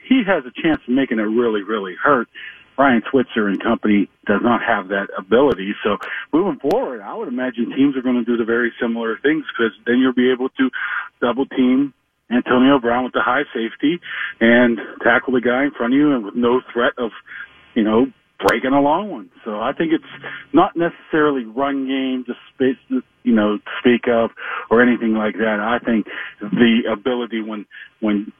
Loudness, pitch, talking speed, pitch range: -18 LUFS, 125 Hz, 190 wpm, 115-135 Hz